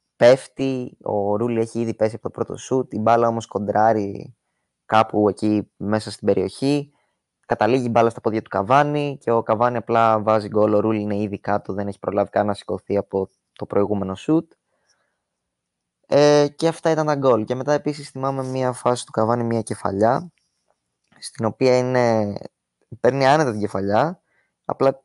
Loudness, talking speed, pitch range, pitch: -21 LUFS, 170 wpm, 105-130 Hz, 115 Hz